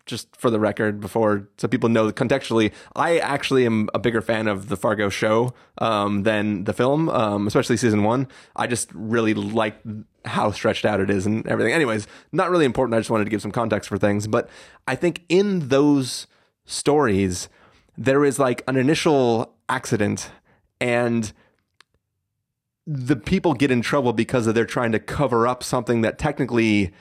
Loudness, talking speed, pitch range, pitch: -21 LUFS, 180 wpm, 105-130 Hz, 115 Hz